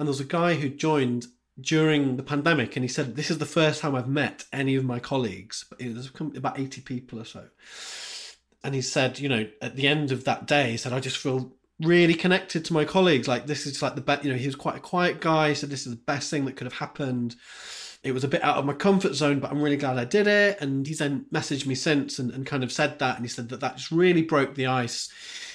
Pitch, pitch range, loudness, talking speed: 140 Hz, 130-155 Hz, -25 LUFS, 270 wpm